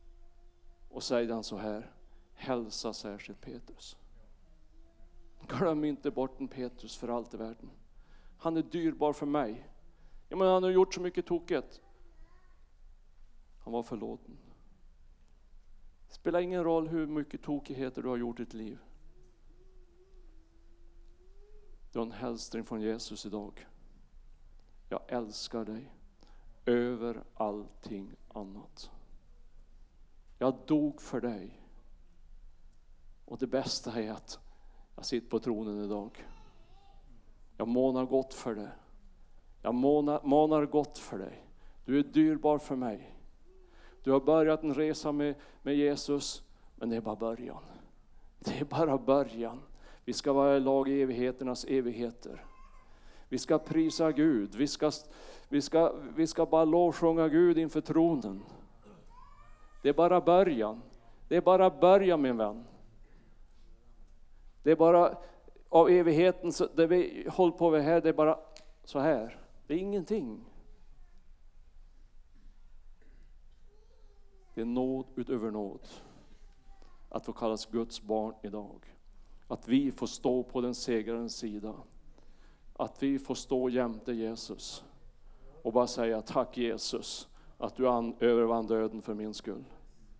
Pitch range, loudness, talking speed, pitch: 105-150 Hz, -31 LUFS, 130 wpm, 125 Hz